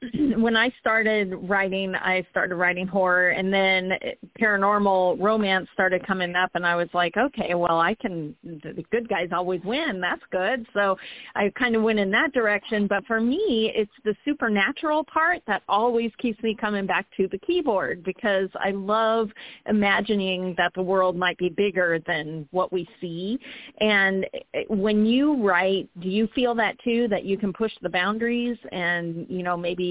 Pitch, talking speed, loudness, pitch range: 200 Hz, 175 wpm, -23 LUFS, 185-225 Hz